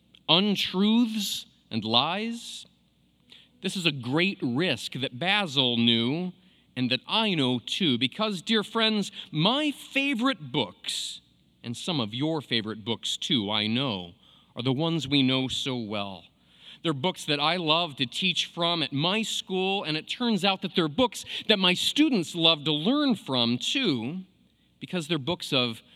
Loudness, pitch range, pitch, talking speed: -26 LUFS, 125-200 Hz, 165 Hz, 155 wpm